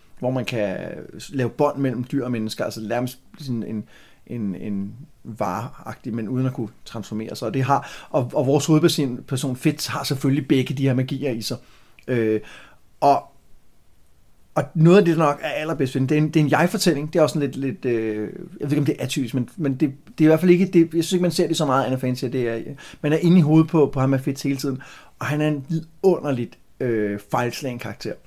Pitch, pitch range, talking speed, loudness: 135 Hz, 120-155 Hz, 235 wpm, -22 LUFS